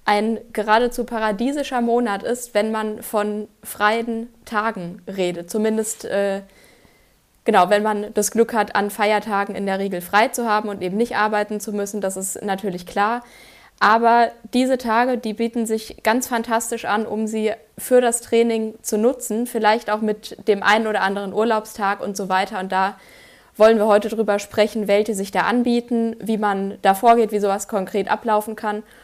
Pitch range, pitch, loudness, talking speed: 205-230 Hz, 215 Hz, -20 LUFS, 175 wpm